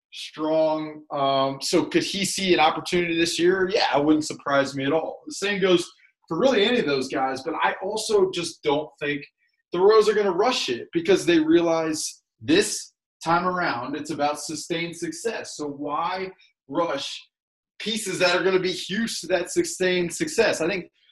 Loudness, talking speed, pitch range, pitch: -23 LUFS, 180 wpm, 155-195 Hz, 170 Hz